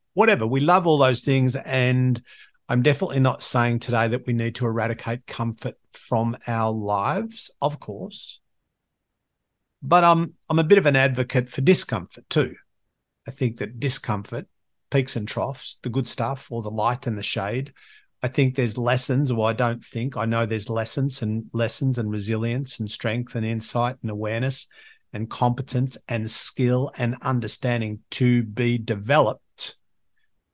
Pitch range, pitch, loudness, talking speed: 115-135 Hz, 120 Hz, -23 LUFS, 165 wpm